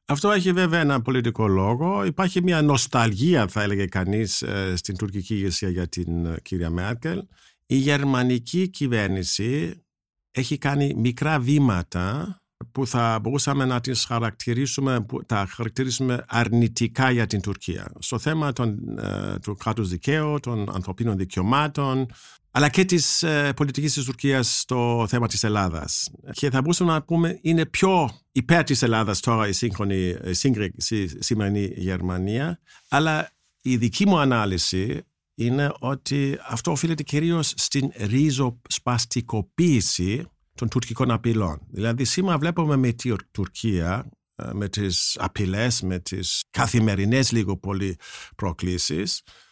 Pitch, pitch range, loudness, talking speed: 120 Hz, 100-140 Hz, -23 LUFS, 130 wpm